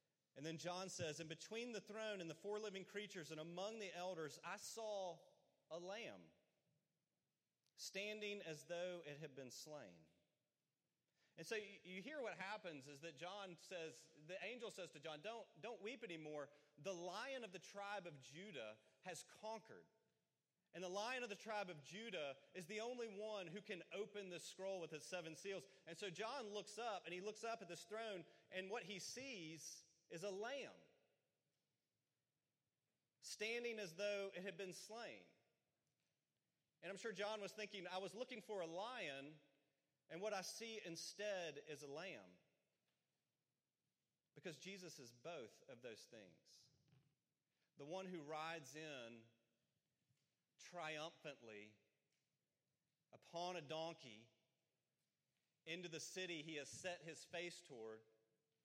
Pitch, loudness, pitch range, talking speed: 175 Hz, -52 LUFS, 150-205 Hz, 150 wpm